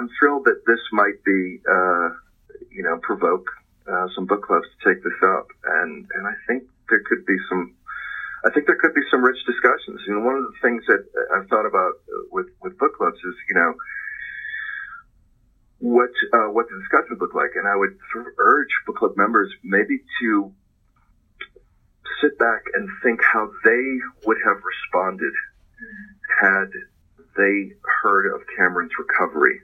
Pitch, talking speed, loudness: 330 Hz, 165 wpm, -20 LUFS